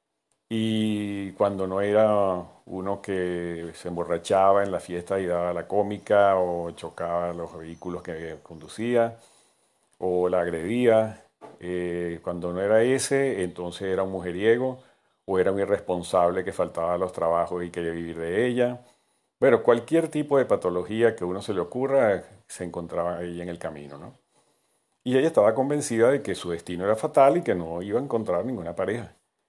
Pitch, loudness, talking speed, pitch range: 95 Hz, -25 LUFS, 165 wpm, 85-110 Hz